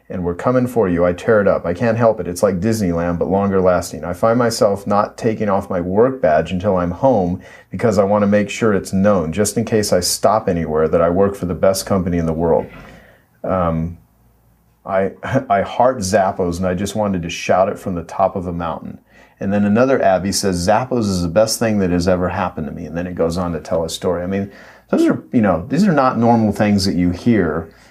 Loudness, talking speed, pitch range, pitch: -17 LUFS, 240 wpm, 90-105 Hz, 95 Hz